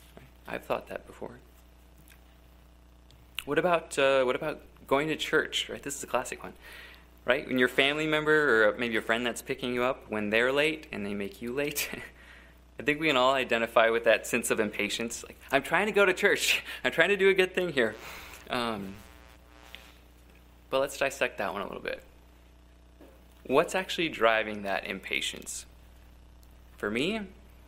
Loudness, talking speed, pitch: -28 LUFS, 175 wpm, 105 Hz